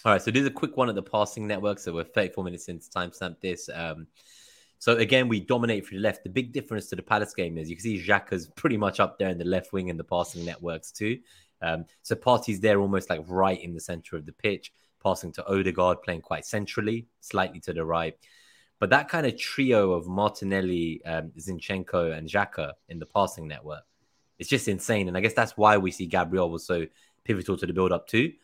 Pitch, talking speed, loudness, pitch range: 95 Hz, 230 wpm, -27 LUFS, 85-105 Hz